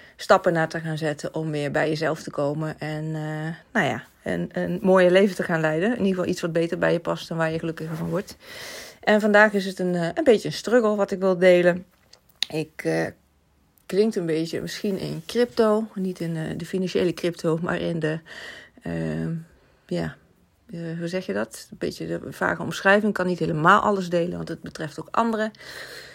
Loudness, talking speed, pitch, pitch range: -24 LUFS, 205 wpm, 175 Hz, 155-190 Hz